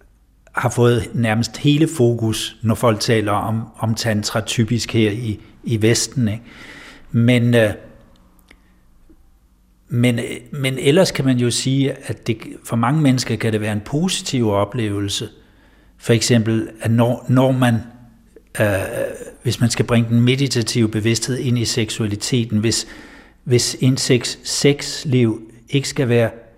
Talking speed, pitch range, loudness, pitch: 140 wpm, 110-125 Hz, -18 LUFS, 115 Hz